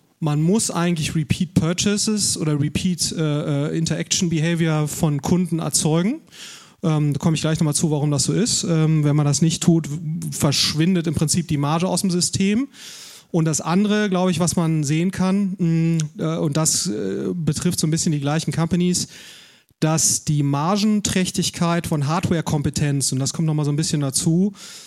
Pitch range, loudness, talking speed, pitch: 155-180 Hz, -20 LUFS, 175 wpm, 165 Hz